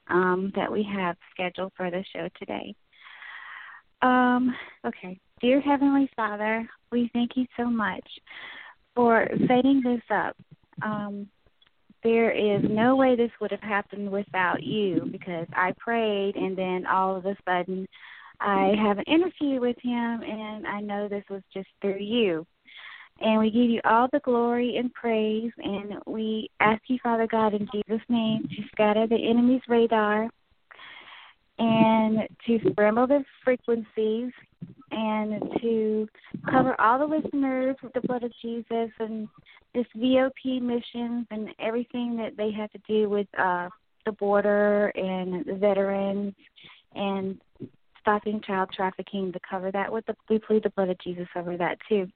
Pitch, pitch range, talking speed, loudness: 215 Hz, 200-240 Hz, 150 wpm, -26 LUFS